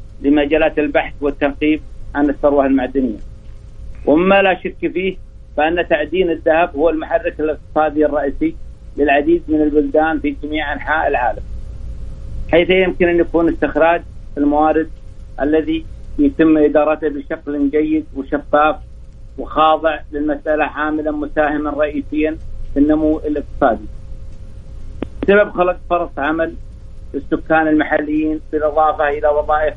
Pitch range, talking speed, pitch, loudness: 140-160 Hz, 105 wpm, 150 Hz, -16 LUFS